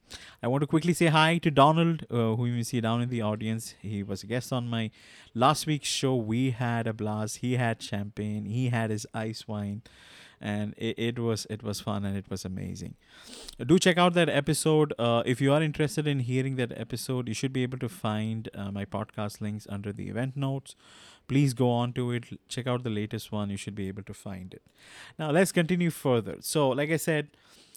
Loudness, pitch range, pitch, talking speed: -28 LUFS, 105-135 Hz, 120 Hz, 220 wpm